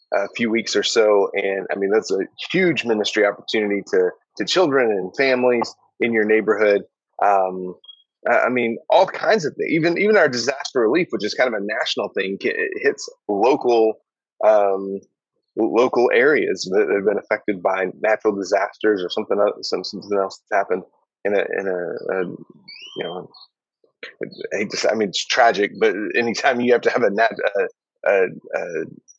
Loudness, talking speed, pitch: -20 LUFS, 175 wpm, 125 Hz